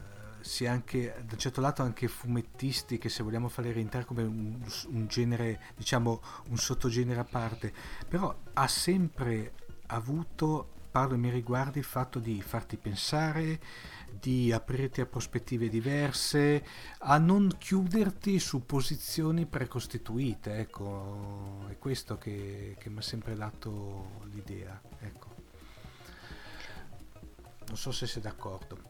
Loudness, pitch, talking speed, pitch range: -33 LUFS, 120 Hz, 130 wpm, 110-130 Hz